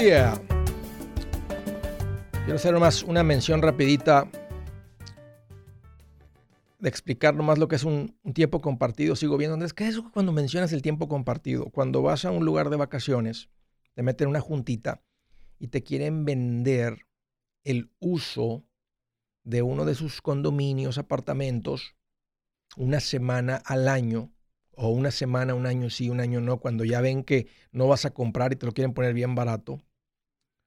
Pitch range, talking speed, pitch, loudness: 115-145 Hz, 155 wpm, 125 Hz, -26 LUFS